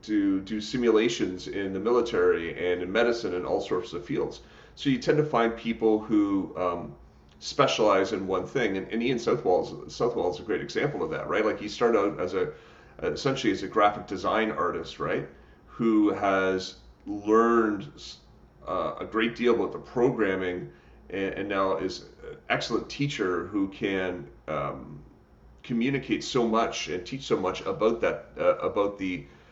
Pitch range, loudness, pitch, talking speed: 95-120 Hz, -27 LUFS, 105 Hz, 170 wpm